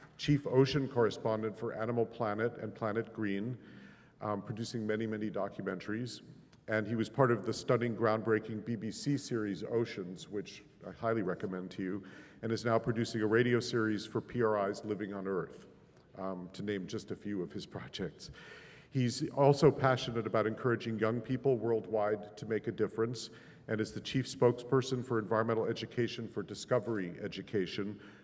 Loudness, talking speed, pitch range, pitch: -35 LUFS, 160 wpm, 105-120 Hz, 115 Hz